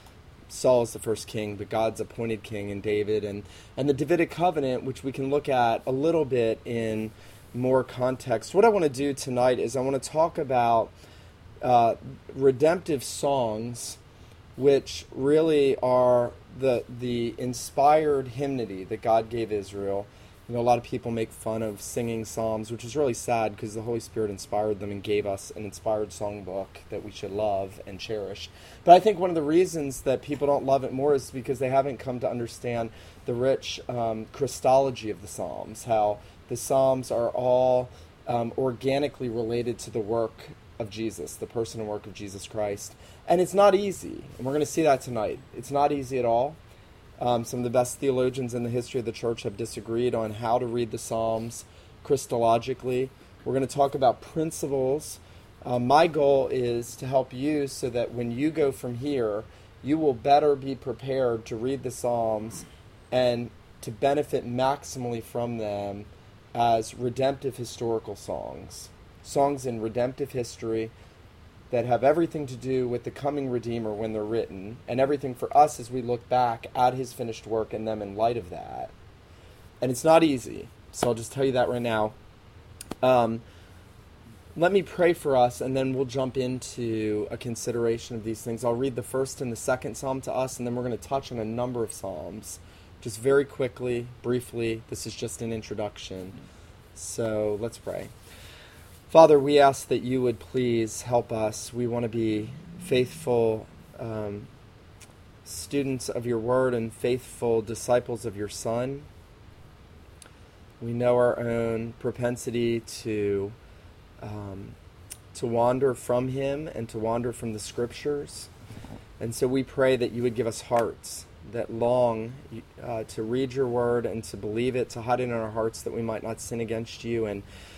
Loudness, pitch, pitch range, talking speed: -27 LUFS, 120 Hz, 110-130 Hz, 180 wpm